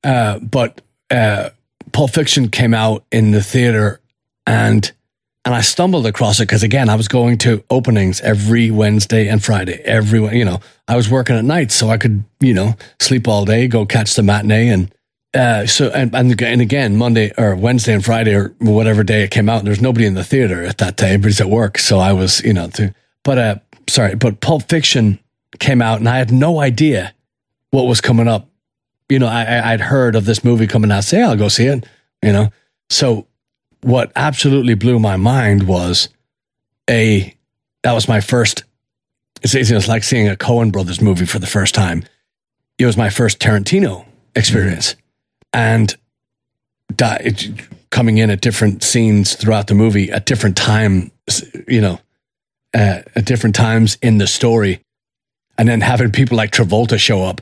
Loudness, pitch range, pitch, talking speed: -14 LUFS, 105-120 Hz, 115 Hz, 185 wpm